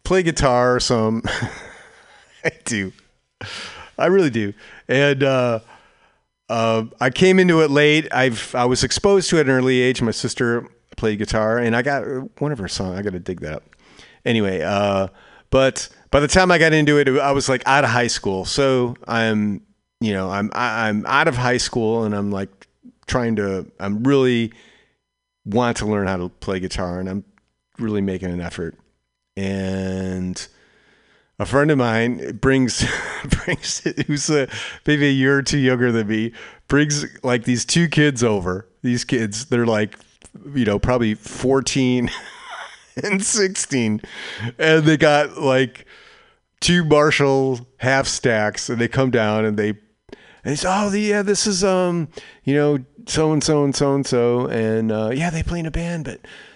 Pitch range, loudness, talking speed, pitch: 105-145 Hz, -19 LUFS, 170 wpm, 125 Hz